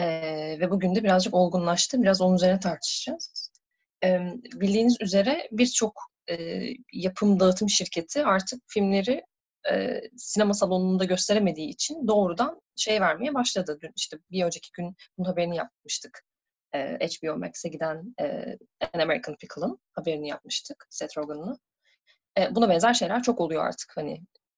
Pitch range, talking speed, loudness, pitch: 175-245 Hz, 135 wpm, -26 LUFS, 195 Hz